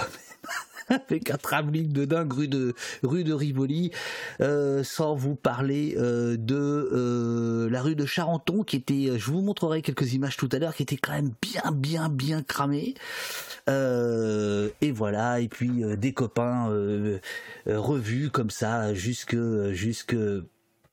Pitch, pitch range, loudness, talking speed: 135 Hz, 115-150 Hz, -28 LUFS, 155 wpm